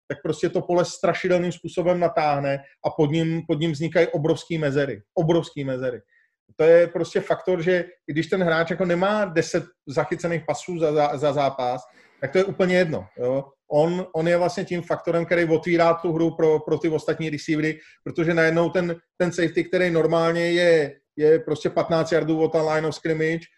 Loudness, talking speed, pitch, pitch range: -22 LUFS, 185 wpm, 165 Hz, 155-175 Hz